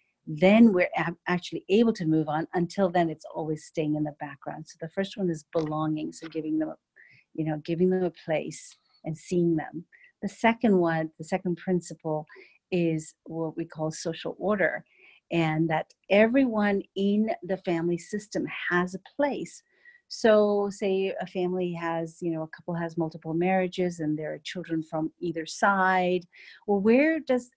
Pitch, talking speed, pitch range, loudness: 175 Hz, 170 wpm, 160-195 Hz, -27 LUFS